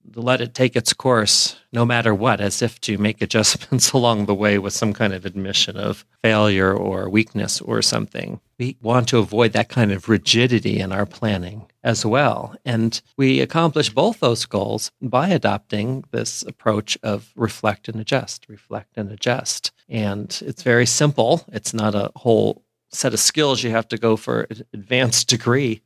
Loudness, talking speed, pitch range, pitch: -19 LUFS, 175 wpm, 105-125 Hz, 115 Hz